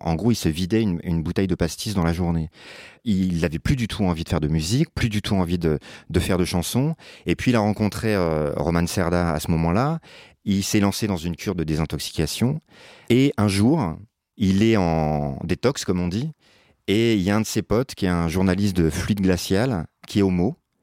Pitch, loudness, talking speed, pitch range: 95 Hz, -22 LUFS, 230 wpm, 85-105 Hz